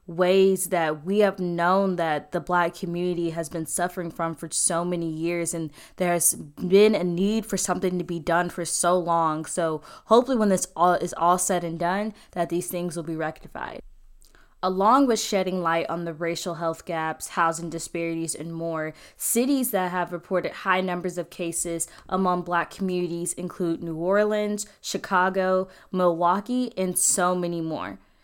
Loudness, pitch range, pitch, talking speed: -25 LUFS, 165-185 Hz, 175 Hz, 170 wpm